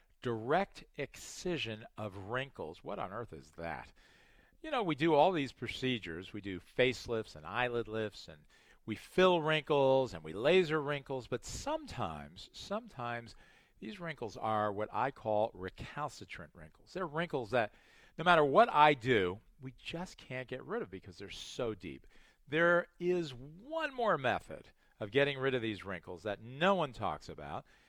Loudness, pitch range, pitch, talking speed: -35 LUFS, 105-150 Hz, 125 Hz, 160 wpm